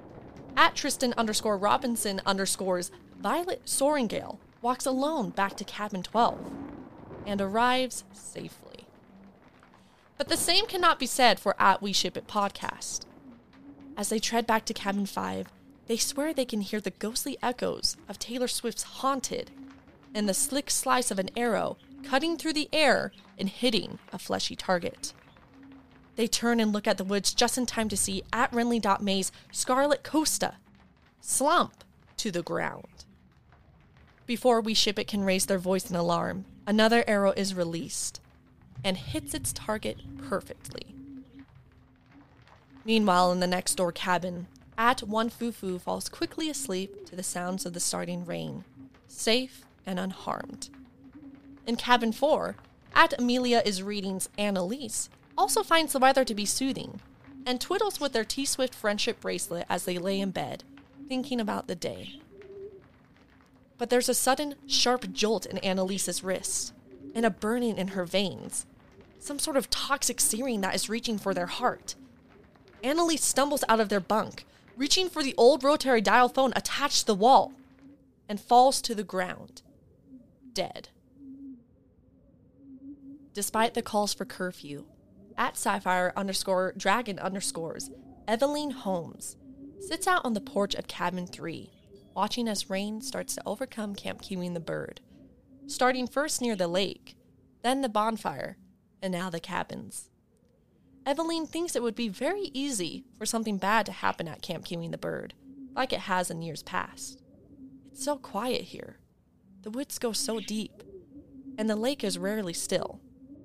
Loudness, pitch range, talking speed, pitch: -28 LUFS, 195-265 Hz, 150 wpm, 225 Hz